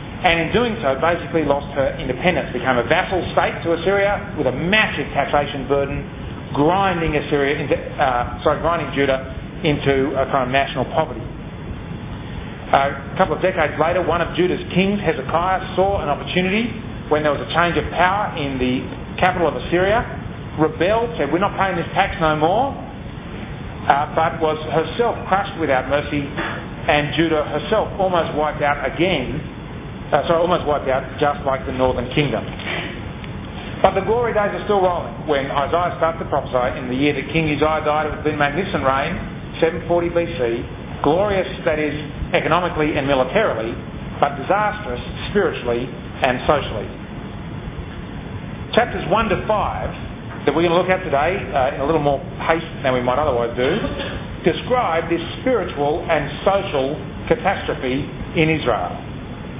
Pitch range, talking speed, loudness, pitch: 140-175 Hz, 160 wpm, -20 LUFS, 155 Hz